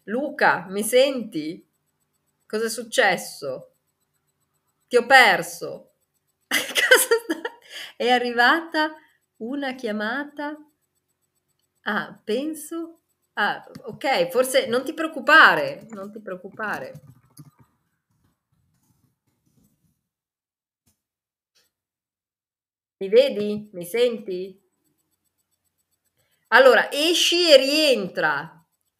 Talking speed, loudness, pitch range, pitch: 70 wpm, -20 LUFS, 215-315 Hz, 265 Hz